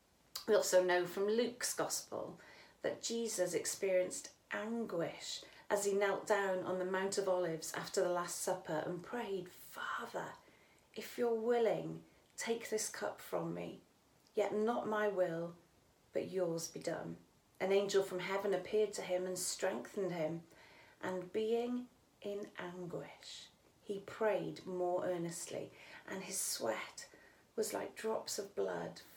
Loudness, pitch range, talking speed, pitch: -39 LUFS, 175-210 Hz, 140 wpm, 185 Hz